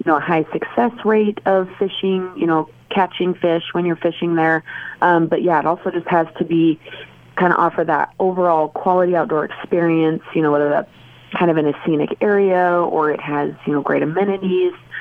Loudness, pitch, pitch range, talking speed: -18 LUFS, 170 Hz, 160-185 Hz, 200 wpm